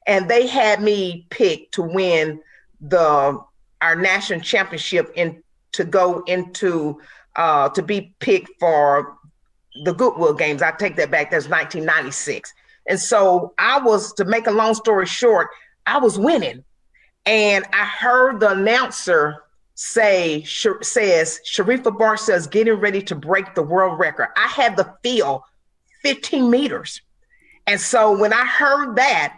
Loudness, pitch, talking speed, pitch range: -18 LUFS, 205 Hz, 145 wpm, 180-250 Hz